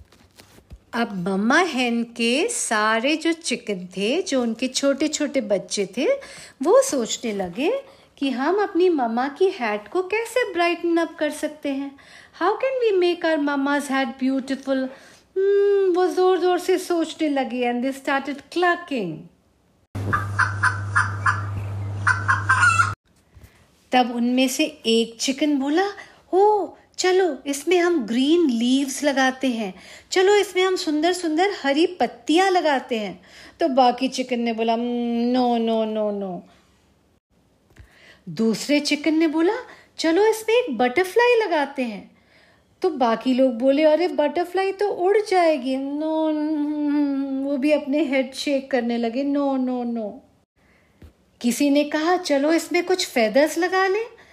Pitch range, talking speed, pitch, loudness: 240-350 Hz, 130 wpm, 280 Hz, -21 LUFS